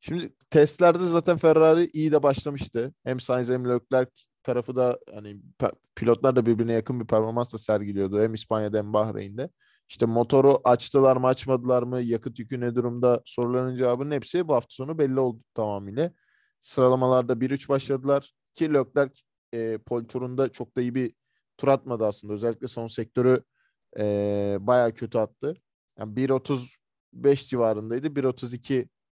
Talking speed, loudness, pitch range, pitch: 145 wpm, -25 LUFS, 115-135 Hz, 125 Hz